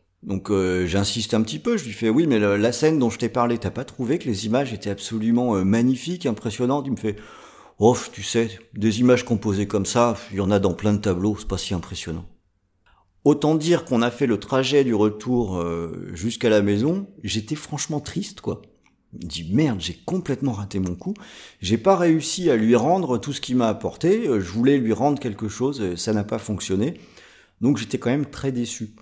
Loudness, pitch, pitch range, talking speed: -22 LUFS, 115 Hz, 100-130 Hz, 215 wpm